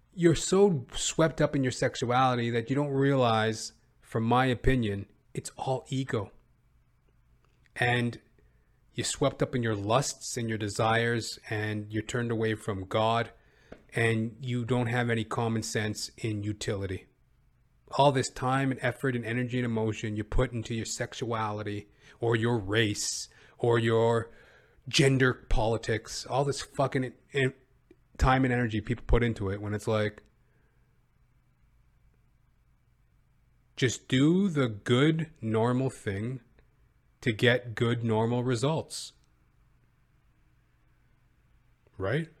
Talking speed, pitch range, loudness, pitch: 125 wpm, 110-130 Hz, -29 LUFS, 120 Hz